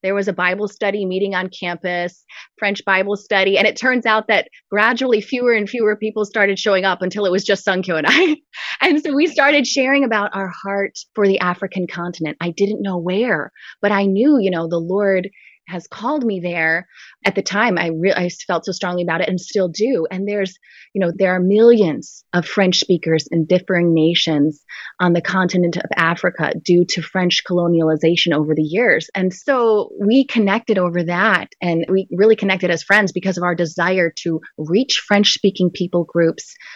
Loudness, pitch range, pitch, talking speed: -17 LUFS, 175-210 Hz, 190 Hz, 195 wpm